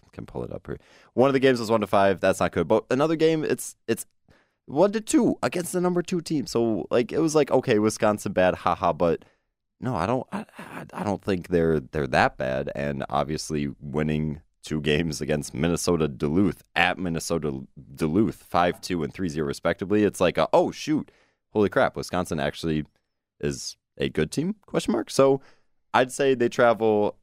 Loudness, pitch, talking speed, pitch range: -25 LUFS, 95 Hz, 190 wpm, 75-130 Hz